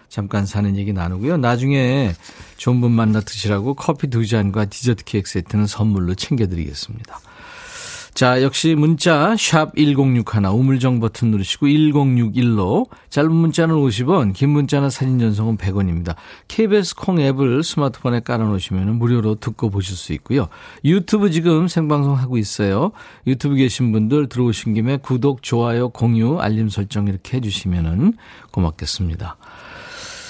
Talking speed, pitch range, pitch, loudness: 315 characters per minute, 105-145 Hz, 120 Hz, -18 LUFS